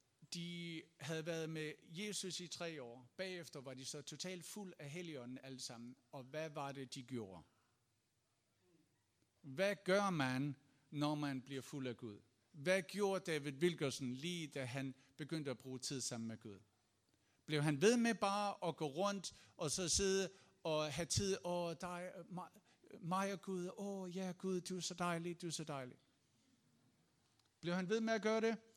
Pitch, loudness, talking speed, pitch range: 155 Hz, -43 LUFS, 180 wpm, 130-180 Hz